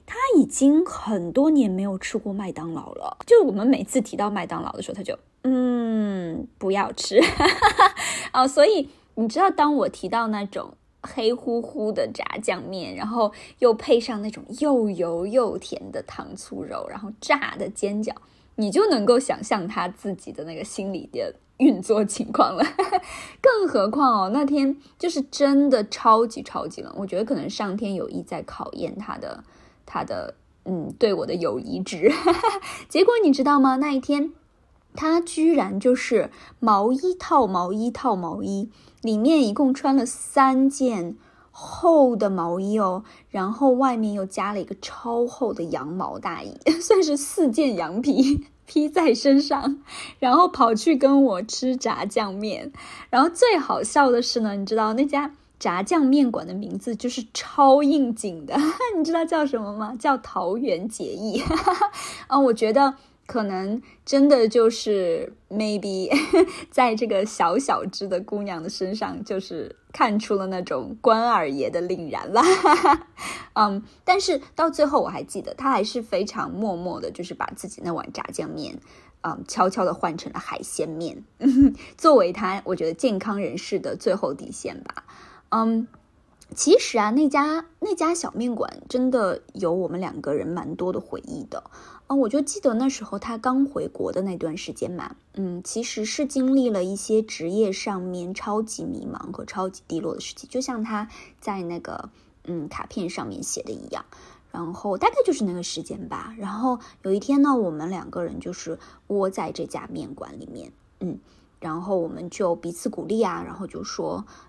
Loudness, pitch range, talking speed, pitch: -23 LUFS, 200-285 Hz, 245 characters per minute, 240 Hz